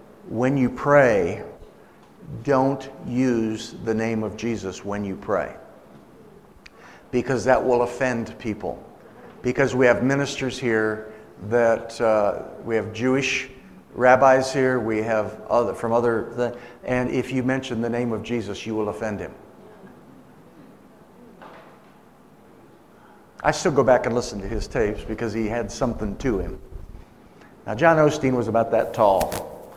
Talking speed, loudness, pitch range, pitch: 135 wpm, -22 LUFS, 110-130 Hz, 120 Hz